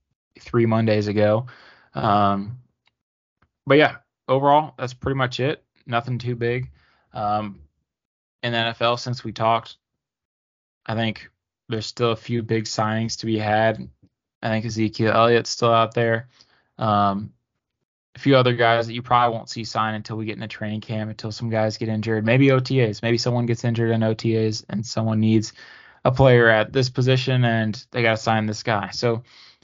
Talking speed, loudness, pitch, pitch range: 170 wpm, -21 LUFS, 115 Hz, 110-120 Hz